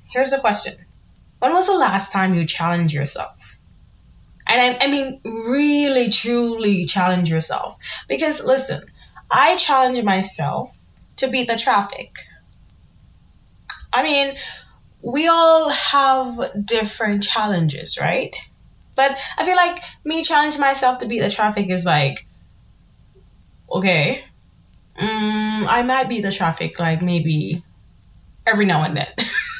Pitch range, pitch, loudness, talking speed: 165-265 Hz, 215 Hz, -18 LUFS, 125 wpm